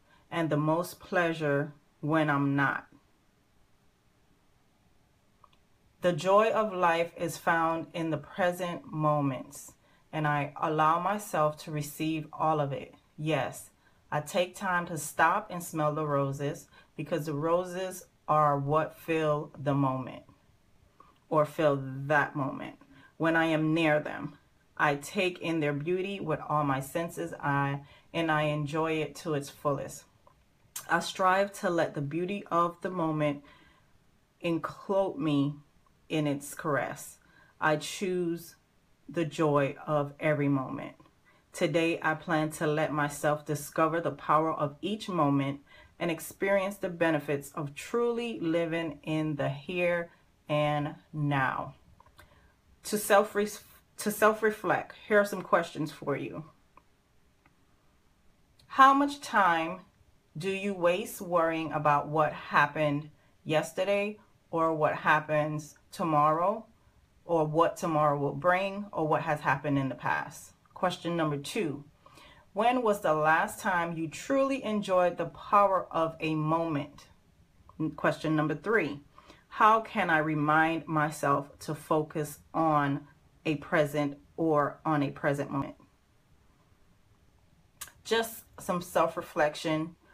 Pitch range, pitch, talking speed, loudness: 145-175 Hz, 155 Hz, 125 wpm, -29 LUFS